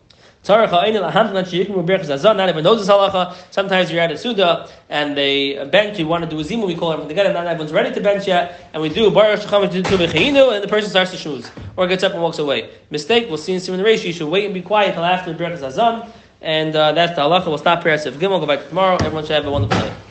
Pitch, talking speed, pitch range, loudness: 180 Hz, 240 wpm, 155-200 Hz, -17 LUFS